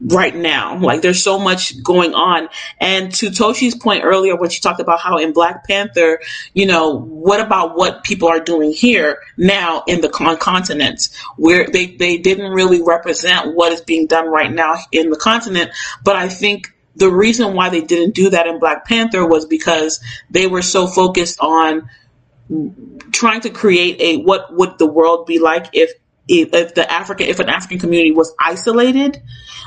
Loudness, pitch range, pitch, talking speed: -14 LUFS, 165-195 Hz, 175 Hz, 180 wpm